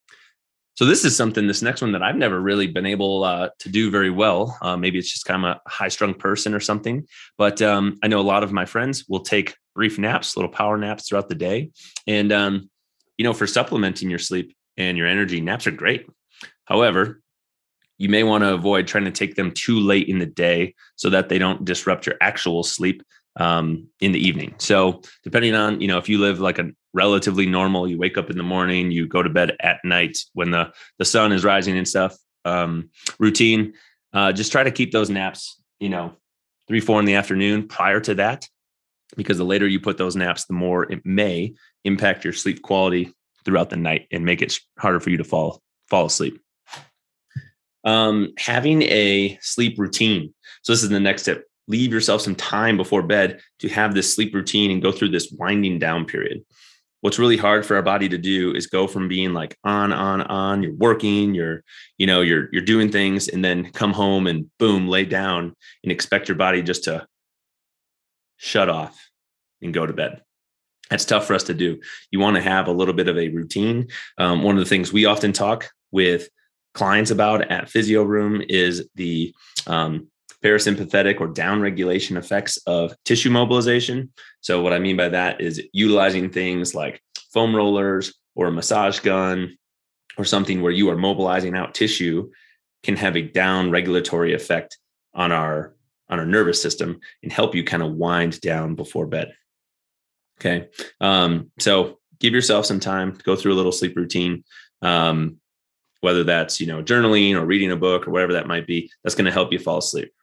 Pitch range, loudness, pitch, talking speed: 90-105 Hz, -20 LUFS, 95 Hz, 200 wpm